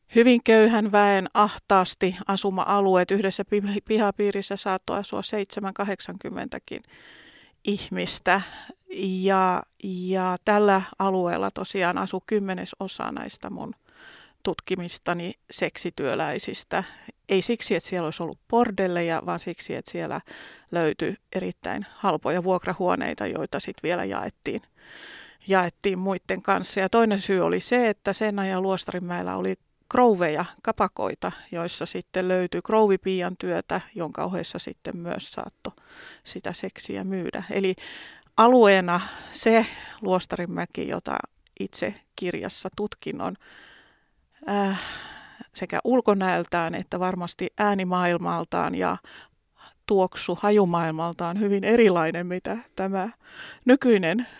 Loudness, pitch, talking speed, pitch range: -25 LUFS, 195 Hz, 100 wpm, 185-210 Hz